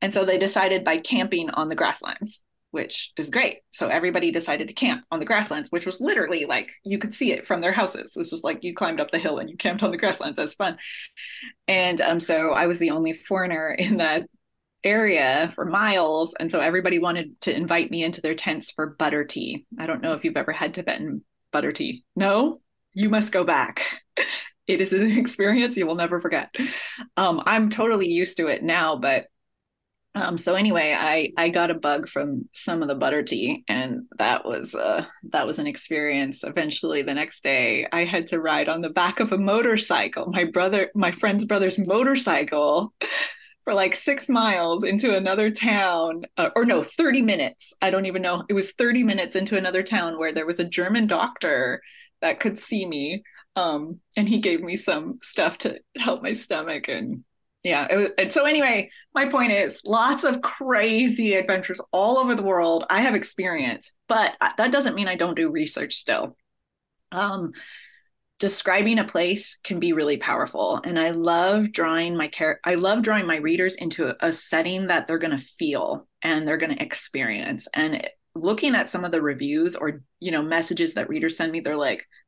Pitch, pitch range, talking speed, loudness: 190 Hz, 170-240 Hz, 195 wpm, -23 LUFS